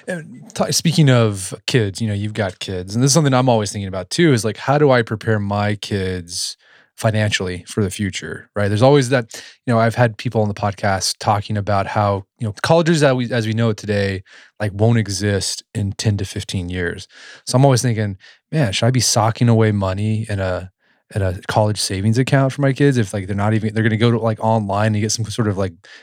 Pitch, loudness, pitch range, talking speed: 110 Hz, -18 LUFS, 100-120 Hz, 235 wpm